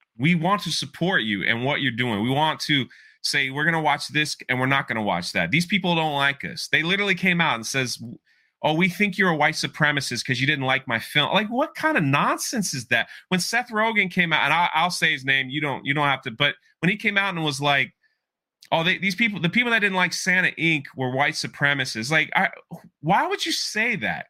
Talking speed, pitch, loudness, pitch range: 250 wpm, 155 Hz, -22 LUFS, 135-185 Hz